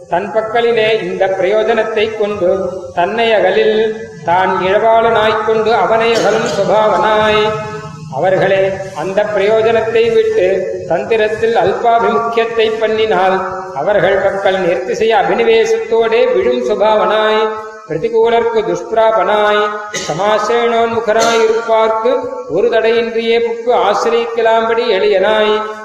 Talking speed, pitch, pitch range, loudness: 80 wpm, 220 Hz, 200-230 Hz, -12 LUFS